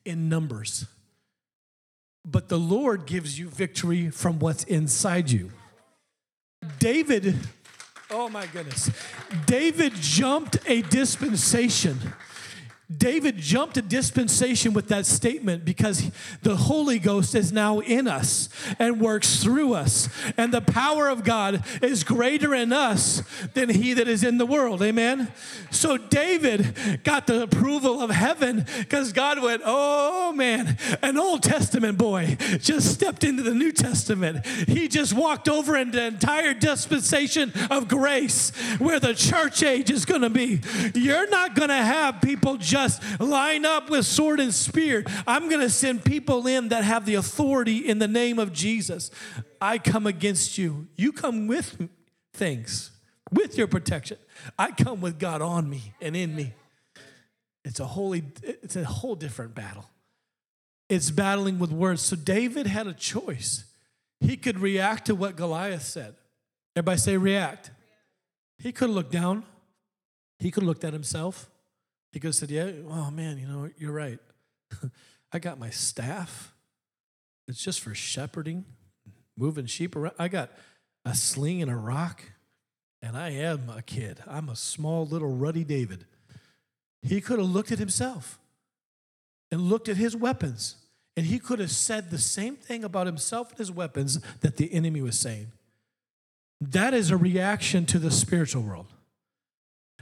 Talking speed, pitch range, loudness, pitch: 155 wpm, 150-240 Hz, -24 LUFS, 190 Hz